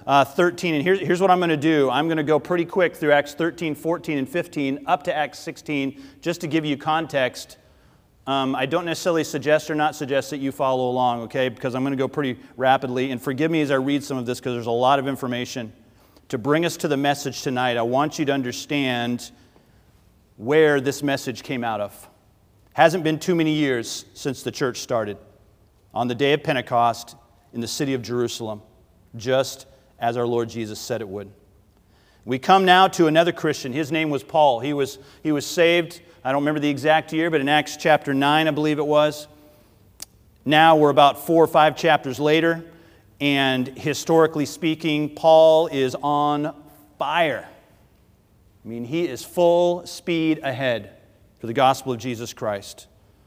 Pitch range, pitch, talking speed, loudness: 125-155 Hz, 140 Hz, 190 wpm, -21 LUFS